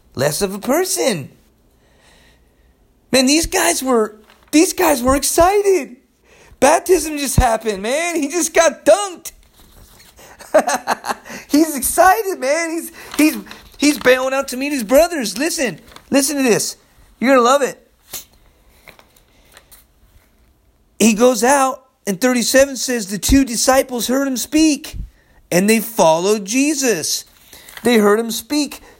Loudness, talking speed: -16 LUFS, 125 wpm